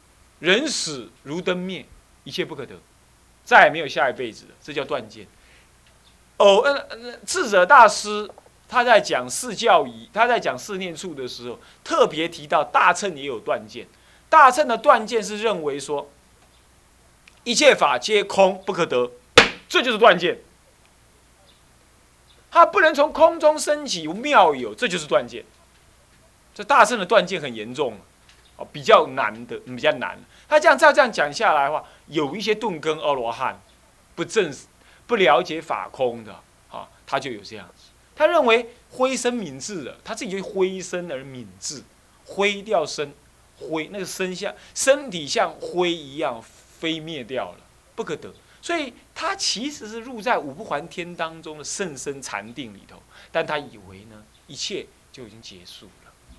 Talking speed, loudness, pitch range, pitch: 230 characters per minute, -20 LUFS, 145-245 Hz, 190 Hz